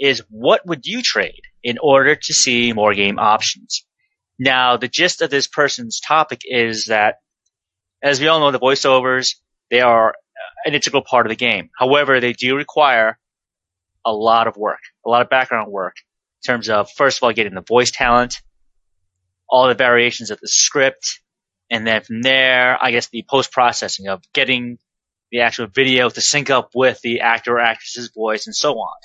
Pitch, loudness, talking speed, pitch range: 120 Hz, -16 LUFS, 185 wpm, 110-135 Hz